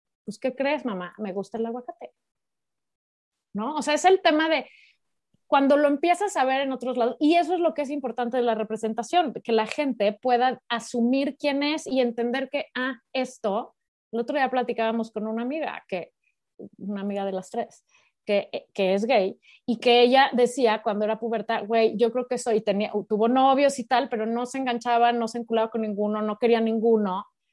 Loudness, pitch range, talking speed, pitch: -24 LUFS, 225-270 Hz, 200 wpm, 240 Hz